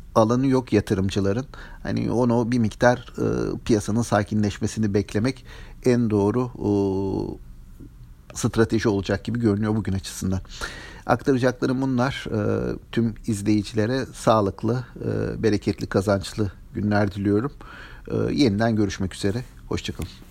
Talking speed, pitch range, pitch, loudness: 105 wpm, 100-120 Hz, 105 Hz, -24 LUFS